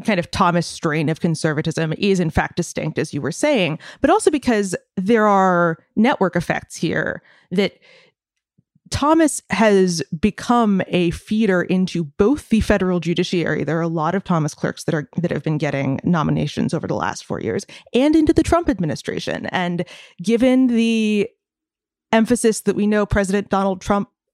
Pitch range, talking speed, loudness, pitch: 170-230 Hz, 165 wpm, -19 LUFS, 195 Hz